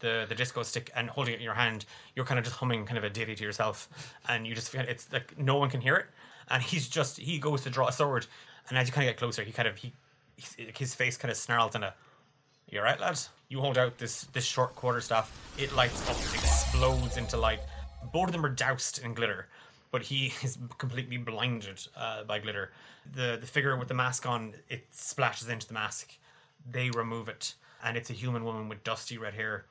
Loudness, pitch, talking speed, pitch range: -32 LUFS, 125 Hz, 230 wpm, 115-130 Hz